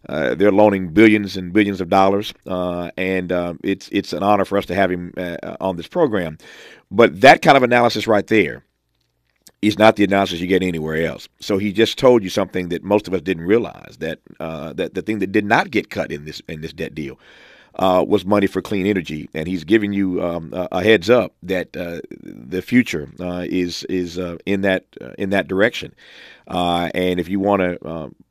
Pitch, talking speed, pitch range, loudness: 95 Hz, 215 wpm, 90-100 Hz, -18 LUFS